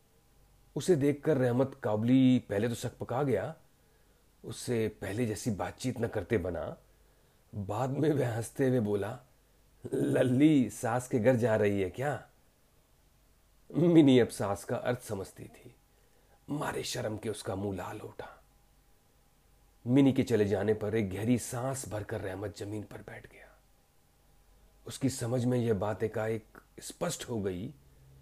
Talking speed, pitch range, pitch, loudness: 140 wpm, 105-130 Hz, 115 Hz, -31 LUFS